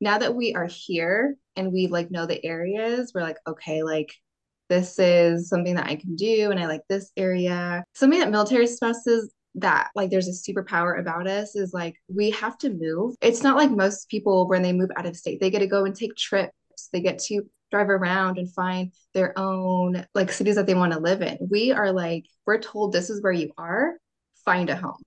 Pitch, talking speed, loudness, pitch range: 190 Hz, 220 wpm, -24 LUFS, 175-210 Hz